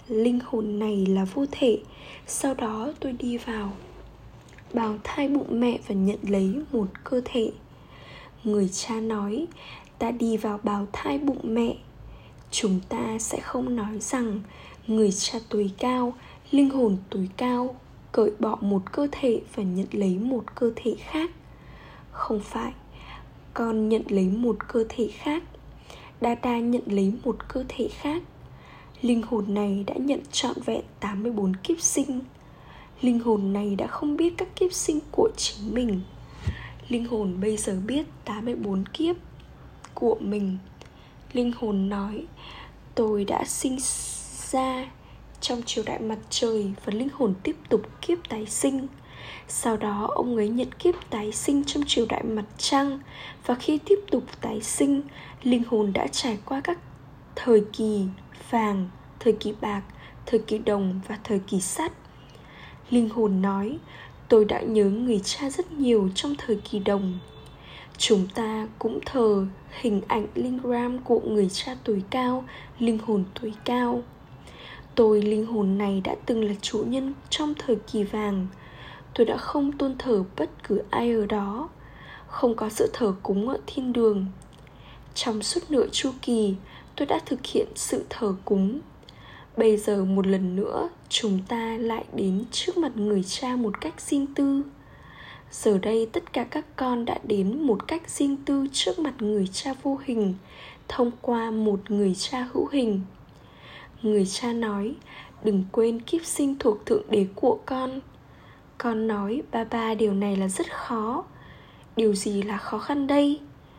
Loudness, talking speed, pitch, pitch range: -26 LUFS, 160 wpm, 225 Hz, 205-255 Hz